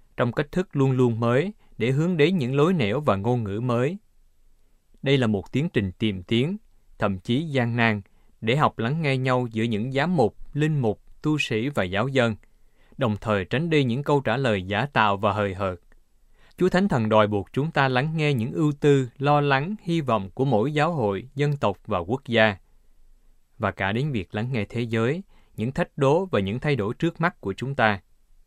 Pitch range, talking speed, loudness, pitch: 105-145 Hz, 215 wpm, -24 LUFS, 120 Hz